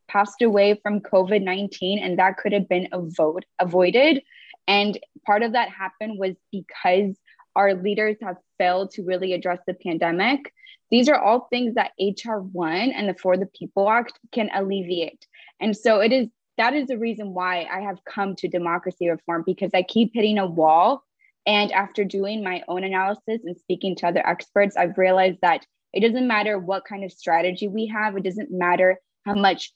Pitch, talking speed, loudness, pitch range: 195 Hz, 185 wpm, -22 LUFS, 185-215 Hz